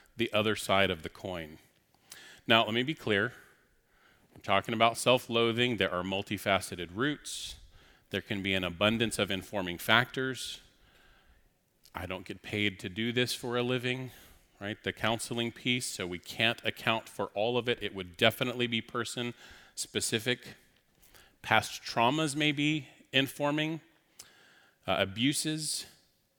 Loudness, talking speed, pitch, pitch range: -31 LUFS, 145 wpm, 115 Hz, 95-125 Hz